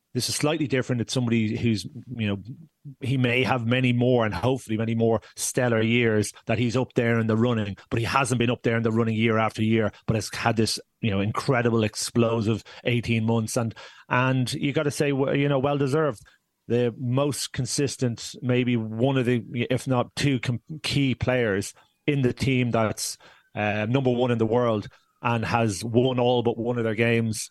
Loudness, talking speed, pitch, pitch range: -24 LUFS, 195 wpm, 120 Hz, 115-130 Hz